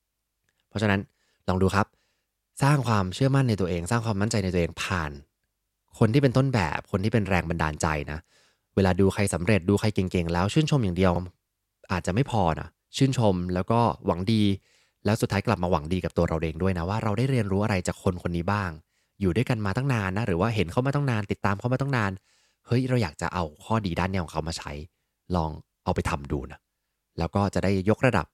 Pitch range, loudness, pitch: 90-110 Hz, -26 LUFS, 100 Hz